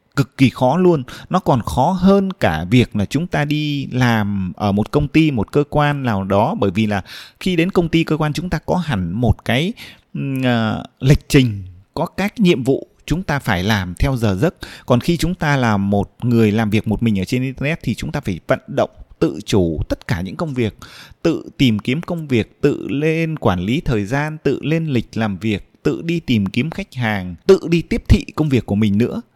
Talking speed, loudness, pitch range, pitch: 225 wpm, -18 LUFS, 105-155 Hz, 130 Hz